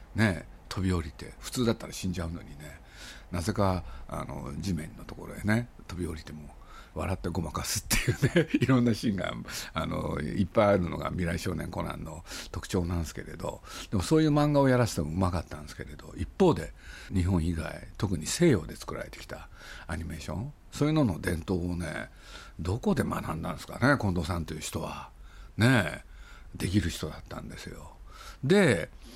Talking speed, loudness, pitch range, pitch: 370 characters per minute, -30 LUFS, 80-105 Hz, 90 Hz